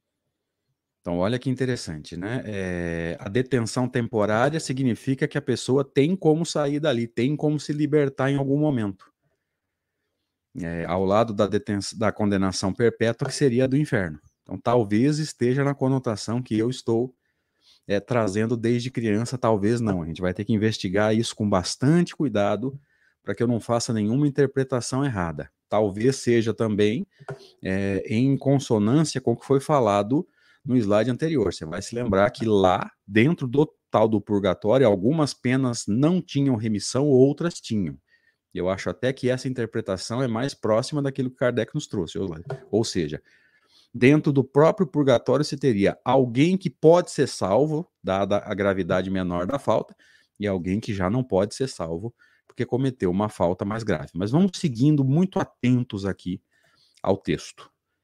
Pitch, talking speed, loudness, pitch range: 120 Hz, 160 wpm, -24 LUFS, 100-135 Hz